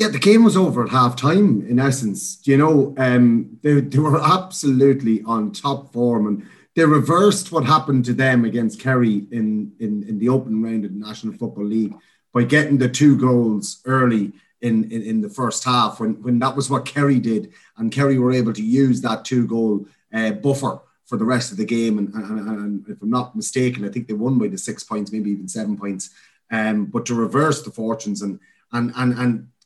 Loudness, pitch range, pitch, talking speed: -19 LUFS, 110-135 Hz, 120 Hz, 210 wpm